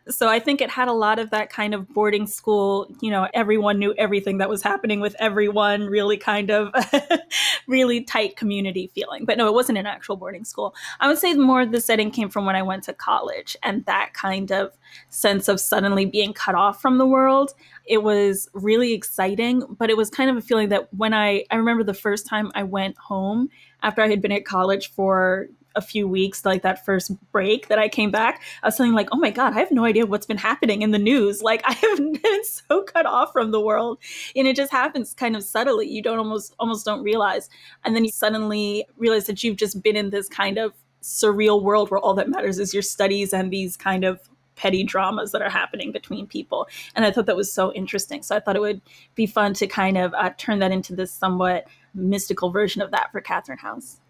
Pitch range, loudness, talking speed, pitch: 195-230 Hz, -21 LUFS, 230 wpm, 210 Hz